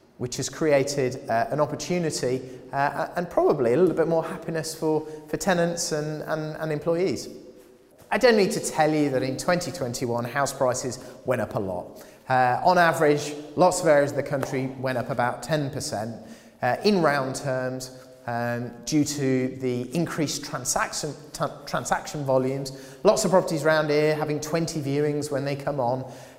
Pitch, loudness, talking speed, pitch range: 145 Hz, -25 LUFS, 170 wpm, 130-155 Hz